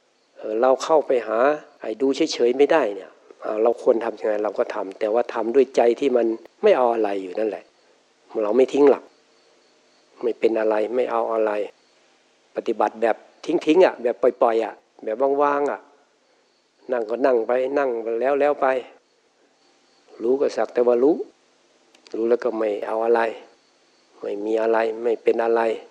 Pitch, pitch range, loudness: 120 Hz, 115-145 Hz, -21 LUFS